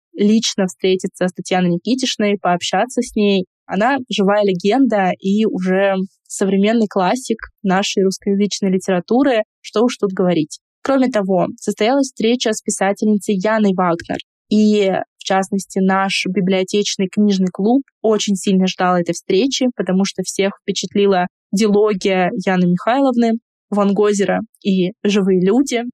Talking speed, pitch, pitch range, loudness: 125 wpm, 200 Hz, 190-215 Hz, -17 LUFS